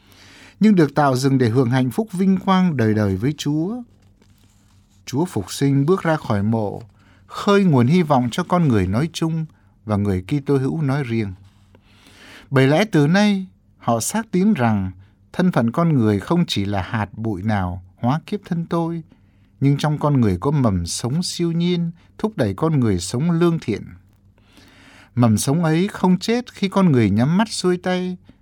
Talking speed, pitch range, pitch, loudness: 180 wpm, 100-170 Hz, 135 Hz, -19 LUFS